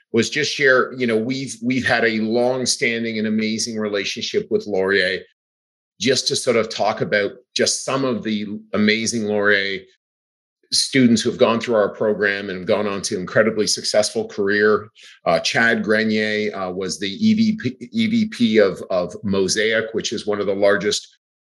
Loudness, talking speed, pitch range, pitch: -19 LUFS, 165 wpm, 100-120 Hz, 110 Hz